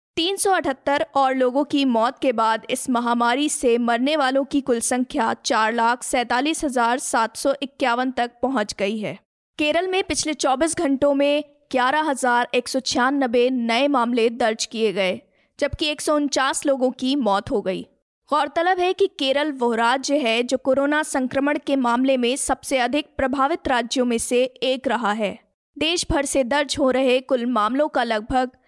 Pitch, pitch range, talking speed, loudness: 265 Hz, 240-290 Hz, 170 wpm, -21 LUFS